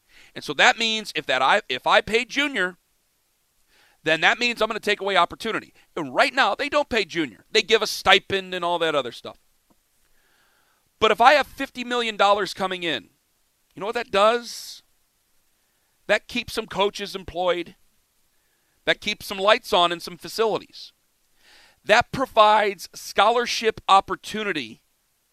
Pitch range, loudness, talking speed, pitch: 190-230 Hz, -21 LUFS, 160 wpm, 210 Hz